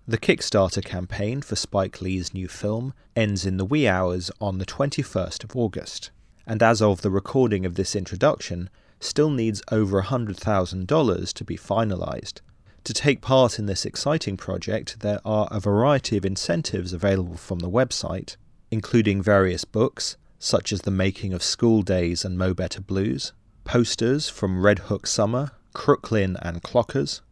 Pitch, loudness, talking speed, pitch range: 100 Hz, -24 LUFS, 160 wpm, 95-115 Hz